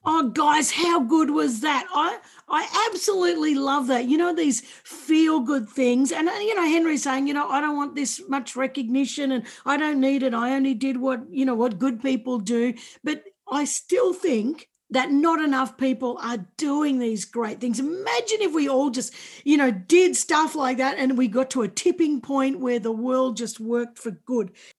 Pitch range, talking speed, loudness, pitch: 250-310 Hz, 200 wpm, -23 LUFS, 270 Hz